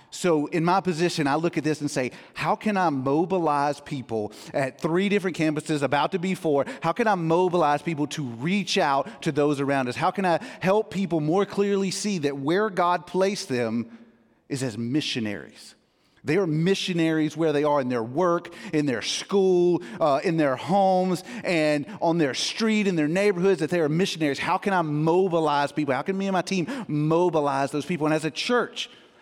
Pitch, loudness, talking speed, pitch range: 160 Hz, -24 LUFS, 195 wpm, 145-185 Hz